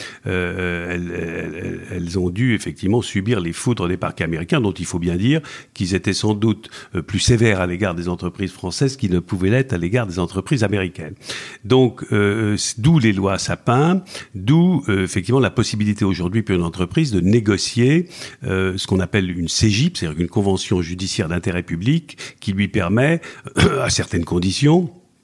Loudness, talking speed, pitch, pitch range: -19 LUFS, 175 wpm, 100 Hz, 90-120 Hz